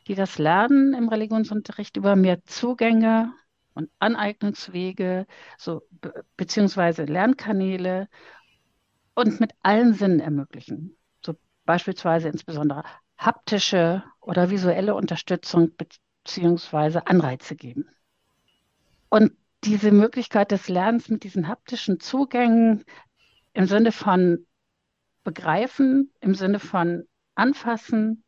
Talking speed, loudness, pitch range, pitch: 100 wpm, -22 LUFS, 170-225 Hz, 195 Hz